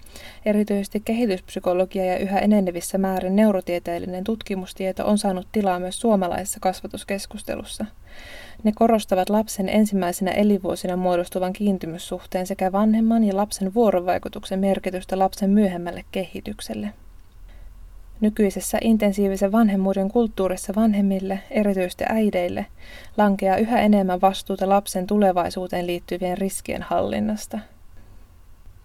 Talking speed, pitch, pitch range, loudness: 95 wpm, 190 Hz, 180-205 Hz, -22 LUFS